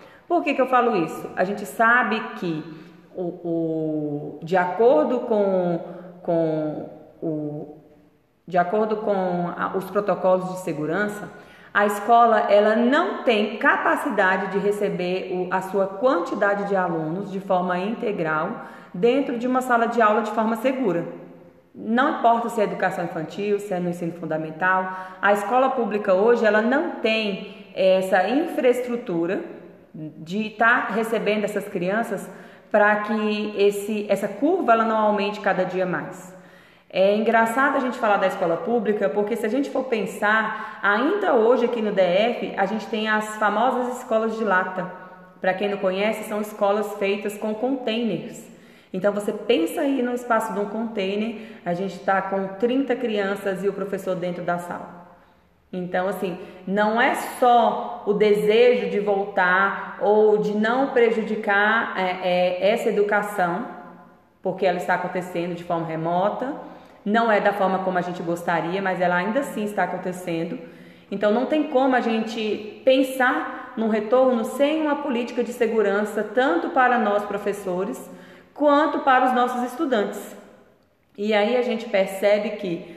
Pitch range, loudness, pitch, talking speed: 185-230 Hz, -22 LUFS, 205 Hz, 155 wpm